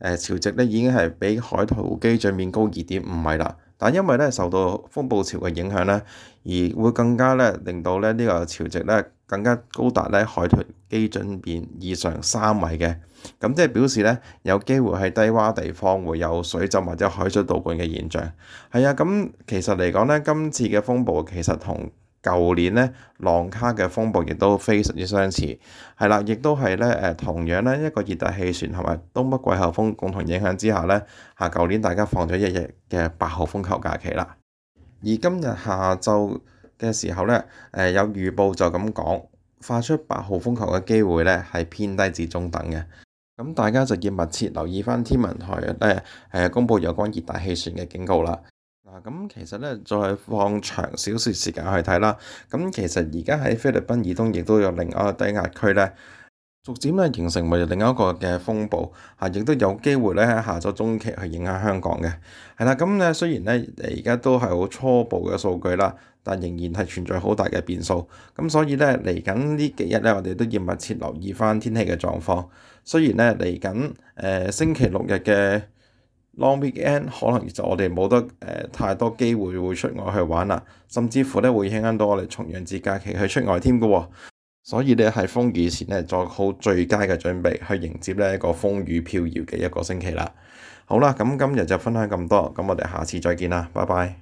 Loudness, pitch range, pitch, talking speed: -22 LUFS, 90-115 Hz, 100 Hz, 290 characters per minute